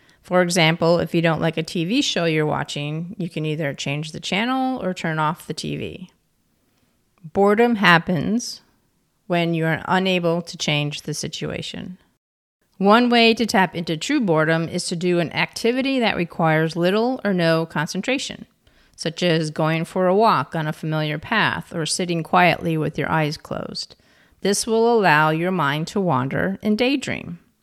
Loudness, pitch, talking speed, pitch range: -20 LUFS, 170 Hz, 165 wpm, 160-200 Hz